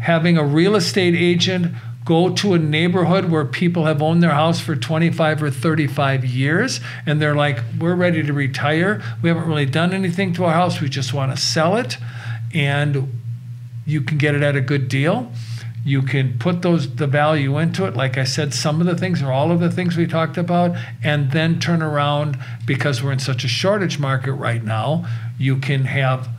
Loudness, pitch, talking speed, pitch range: -18 LUFS, 150 Hz, 200 wpm, 130-165 Hz